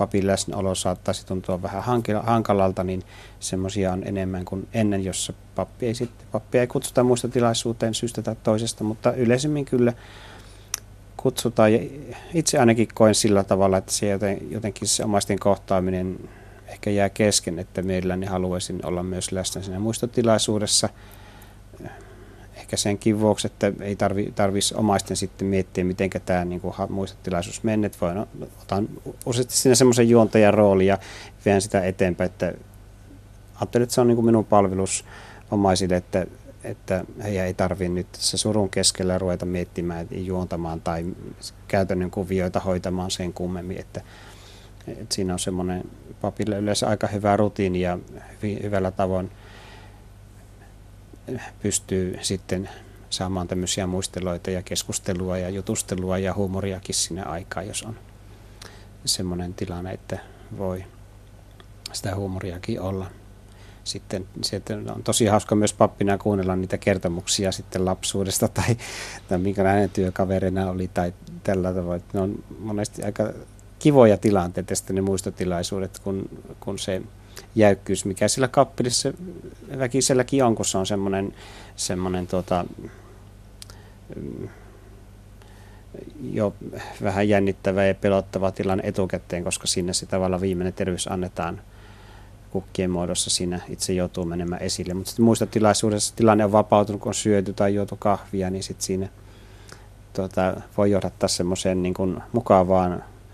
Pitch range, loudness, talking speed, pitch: 95-105 Hz, -23 LUFS, 125 wpm, 100 Hz